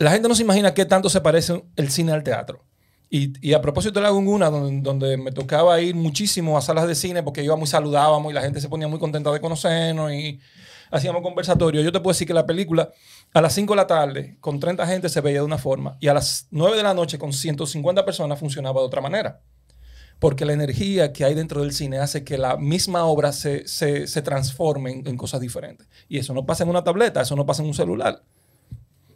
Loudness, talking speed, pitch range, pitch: -21 LUFS, 235 wpm, 140-170 Hz, 155 Hz